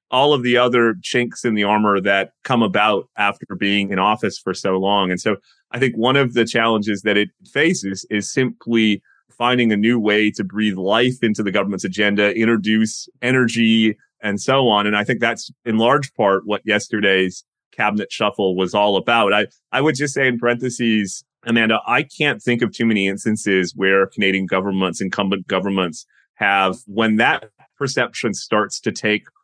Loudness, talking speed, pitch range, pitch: -18 LUFS, 180 wpm, 100-120 Hz, 105 Hz